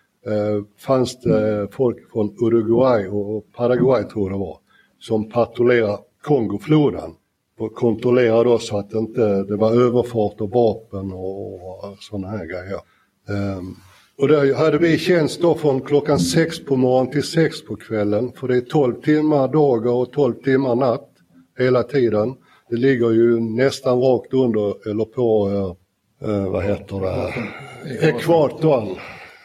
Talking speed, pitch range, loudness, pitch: 150 wpm, 105-130 Hz, -19 LUFS, 115 Hz